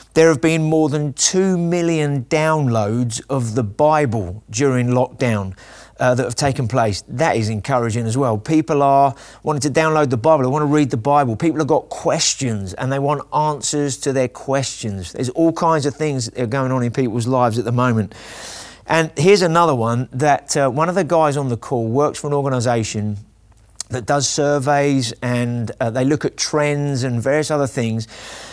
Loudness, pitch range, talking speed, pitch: -18 LUFS, 120-150 Hz, 195 wpm, 135 Hz